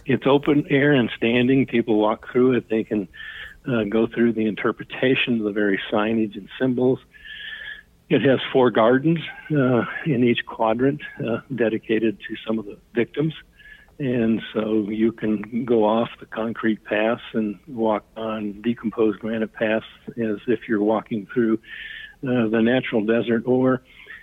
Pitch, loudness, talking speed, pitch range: 115 Hz, -22 LUFS, 155 wpm, 110-130 Hz